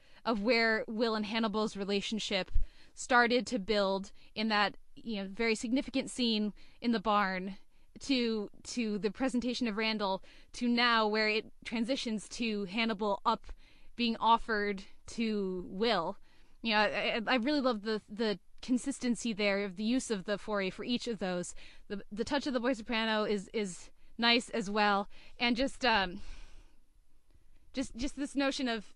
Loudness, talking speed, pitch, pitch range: -32 LUFS, 160 wpm, 225 Hz, 210-245 Hz